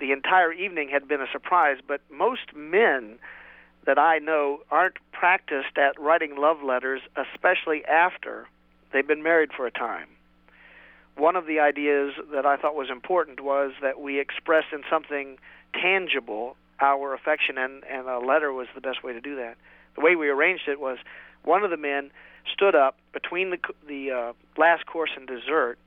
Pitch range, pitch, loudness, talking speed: 135-160 Hz, 140 Hz, -24 LUFS, 175 wpm